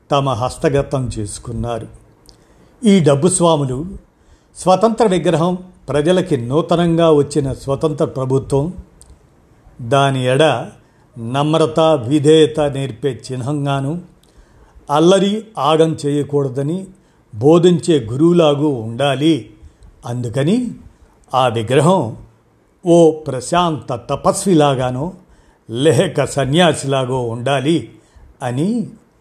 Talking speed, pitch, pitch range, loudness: 70 wpm, 145 Hz, 130-165 Hz, -16 LUFS